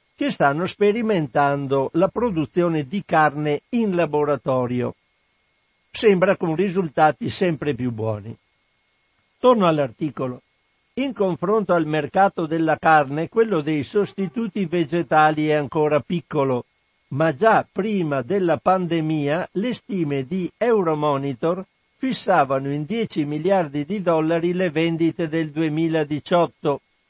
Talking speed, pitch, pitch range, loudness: 110 wpm, 165 Hz, 145-190 Hz, -21 LUFS